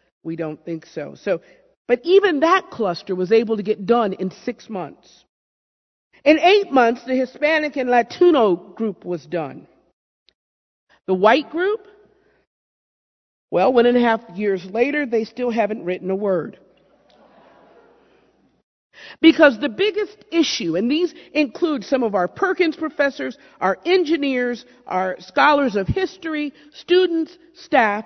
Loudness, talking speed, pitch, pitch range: -19 LUFS, 135 wpm, 255 Hz, 200-325 Hz